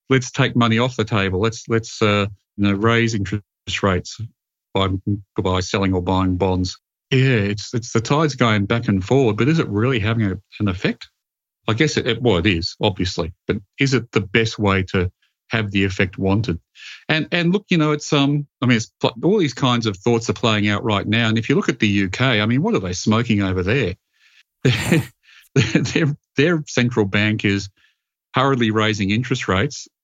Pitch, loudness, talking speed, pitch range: 110 Hz, -19 LUFS, 200 wpm, 100-125 Hz